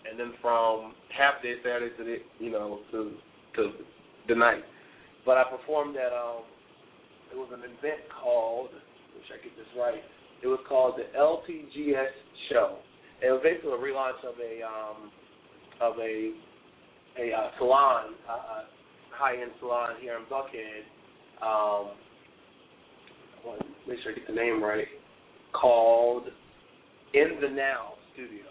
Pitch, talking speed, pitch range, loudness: 125 Hz, 155 wpm, 115-140 Hz, -29 LUFS